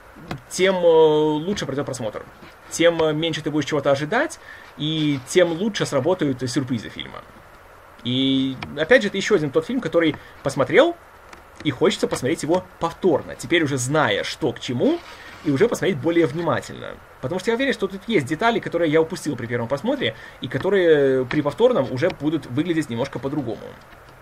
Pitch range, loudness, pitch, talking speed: 140-180 Hz, -21 LUFS, 160 Hz, 160 wpm